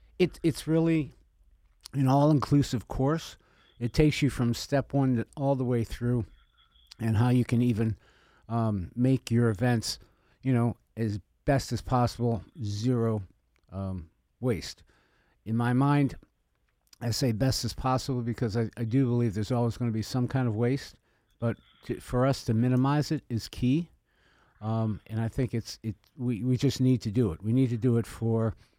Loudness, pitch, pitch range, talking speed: -28 LUFS, 120 Hz, 110-130 Hz, 175 wpm